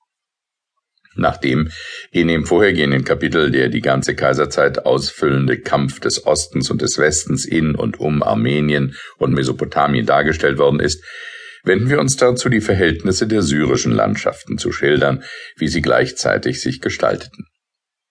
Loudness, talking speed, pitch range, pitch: -17 LUFS, 135 wpm, 70-110 Hz, 80 Hz